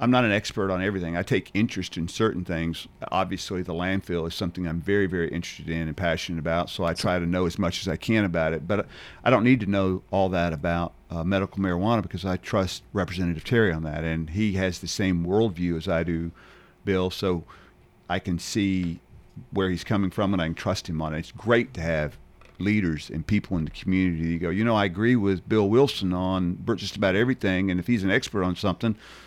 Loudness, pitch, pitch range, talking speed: -26 LUFS, 95 Hz, 85-100 Hz, 230 wpm